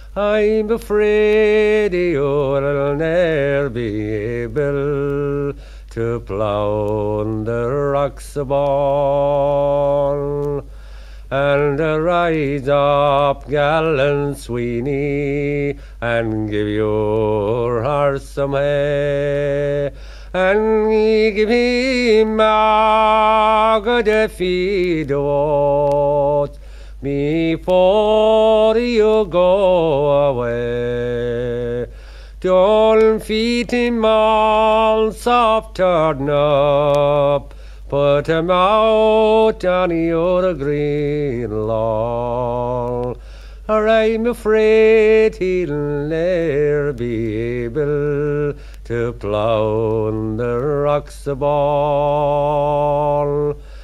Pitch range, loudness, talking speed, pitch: 140-200 Hz, -17 LUFS, 65 wpm, 145 Hz